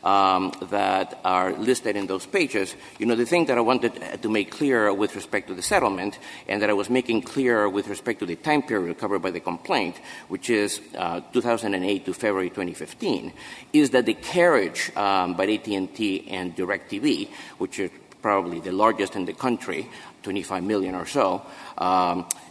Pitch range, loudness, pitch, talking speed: 95-130 Hz, -24 LUFS, 110 Hz, 180 wpm